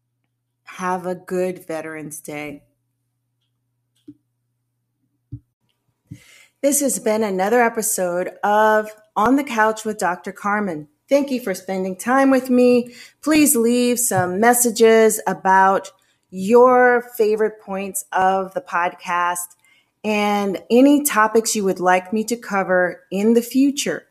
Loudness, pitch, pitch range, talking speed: -18 LUFS, 190 Hz, 170-230 Hz, 115 wpm